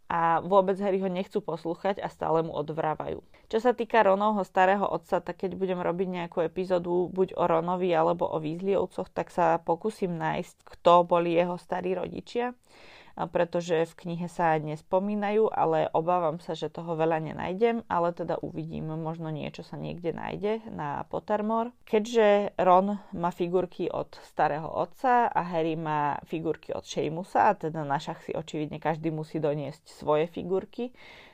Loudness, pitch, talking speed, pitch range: -28 LUFS, 175 Hz, 160 wpm, 160-195 Hz